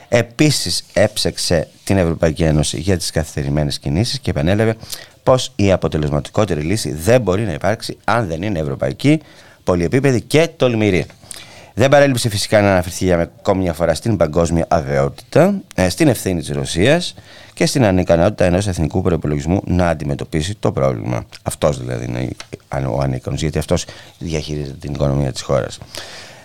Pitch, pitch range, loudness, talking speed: 90 Hz, 75-110 Hz, -17 LUFS, 145 wpm